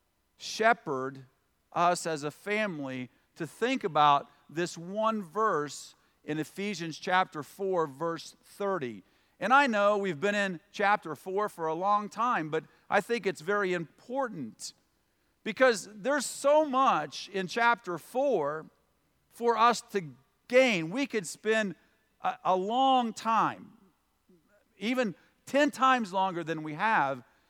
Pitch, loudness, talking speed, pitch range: 200 Hz, -29 LUFS, 130 wpm, 160-230 Hz